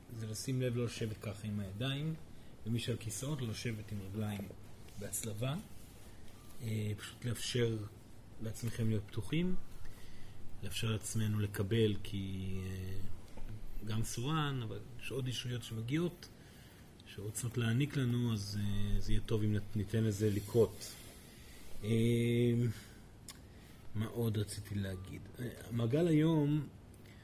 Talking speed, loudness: 105 wpm, -37 LUFS